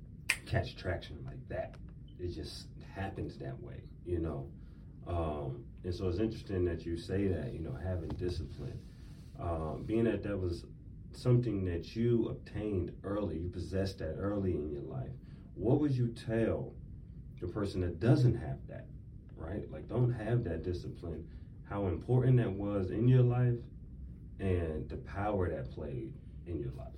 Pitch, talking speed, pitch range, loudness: 95 Hz, 160 wpm, 85-115 Hz, -35 LUFS